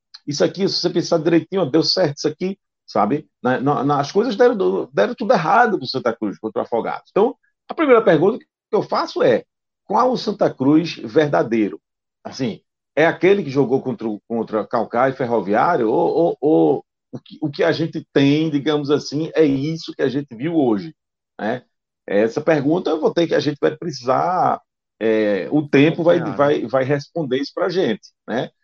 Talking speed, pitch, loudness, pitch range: 190 wpm, 155 Hz, -19 LUFS, 135-170 Hz